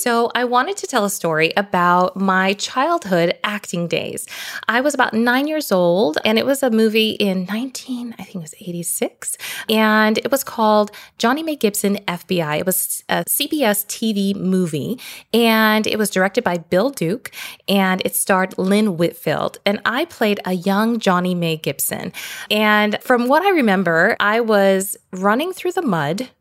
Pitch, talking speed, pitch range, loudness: 210 Hz, 175 wpm, 185-240 Hz, -18 LUFS